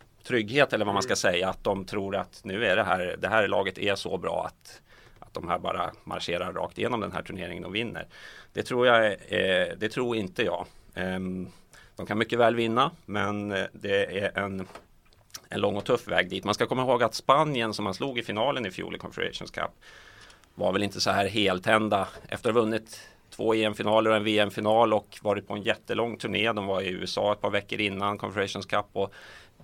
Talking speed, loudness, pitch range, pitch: 210 wpm, -27 LUFS, 100-110 Hz, 105 Hz